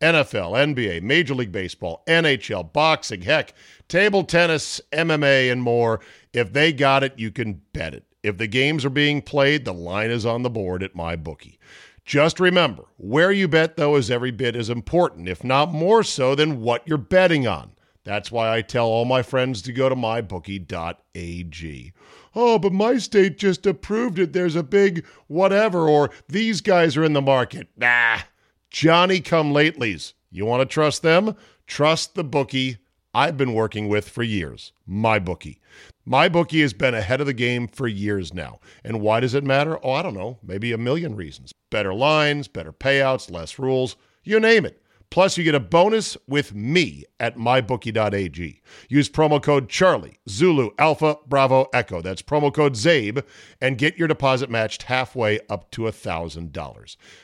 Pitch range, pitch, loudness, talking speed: 110-155 Hz, 130 Hz, -20 LUFS, 175 wpm